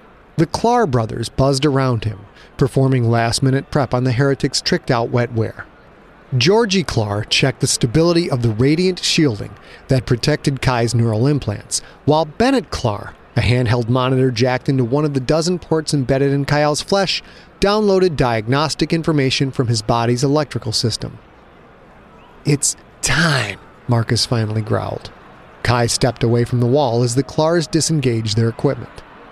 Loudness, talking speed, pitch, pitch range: -17 LUFS, 145 wpm, 135 Hz, 120-150 Hz